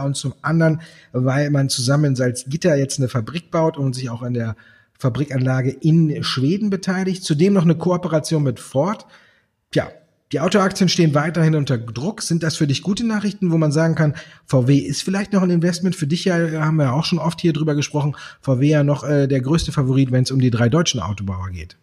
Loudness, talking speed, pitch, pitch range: -19 LUFS, 210 wpm, 150 Hz, 135-170 Hz